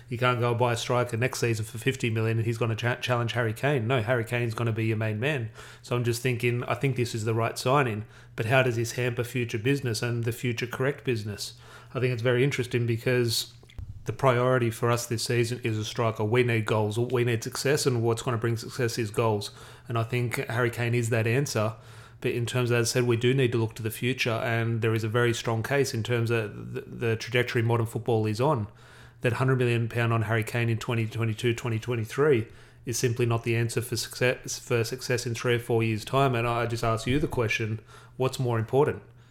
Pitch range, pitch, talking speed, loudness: 115-125 Hz, 120 Hz, 235 wpm, -27 LUFS